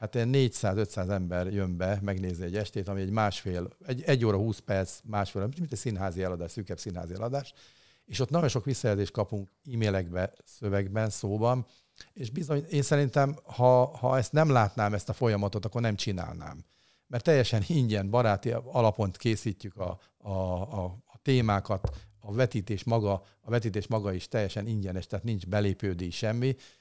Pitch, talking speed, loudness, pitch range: 105 Hz, 165 wpm, -30 LUFS, 100-120 Hz